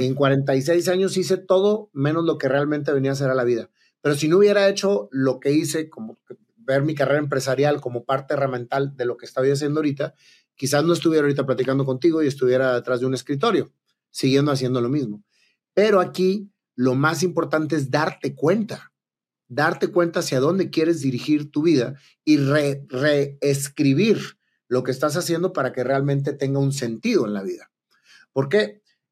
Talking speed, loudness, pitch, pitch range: 180 wpm, -21 LUFS, 145 Hz, 135-165 Hz